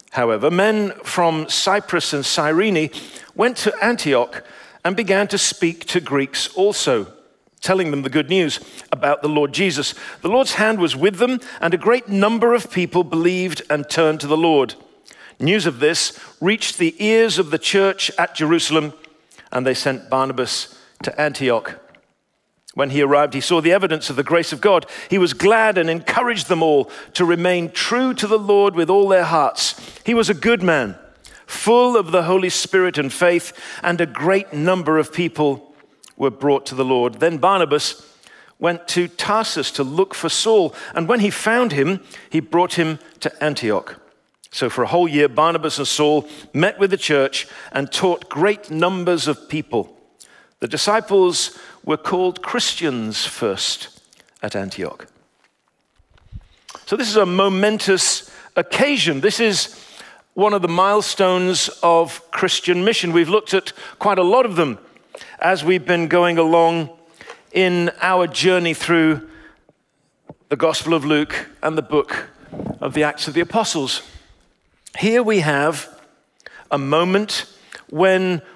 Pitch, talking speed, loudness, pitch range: 175 Hz, 160 wpm, -18 LUFS, 150-195 Hz